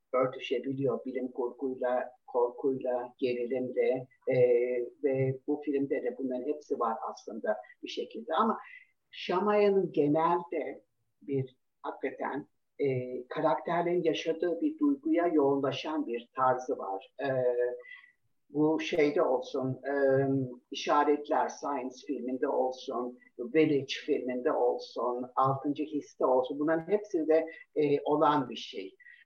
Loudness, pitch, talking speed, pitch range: -31 LUFS, 140 Hz, 105 wpm, 130-165 Hz